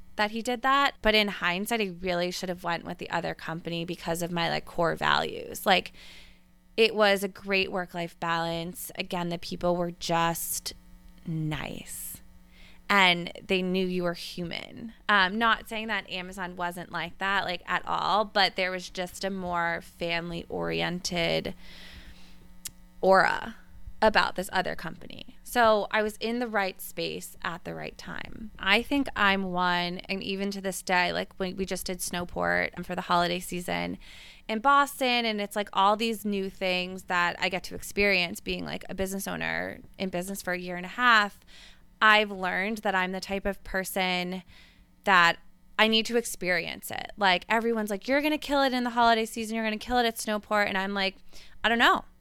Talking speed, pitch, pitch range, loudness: 185 wpm, 185 Hz, 175-215 Hz, -27 LUFS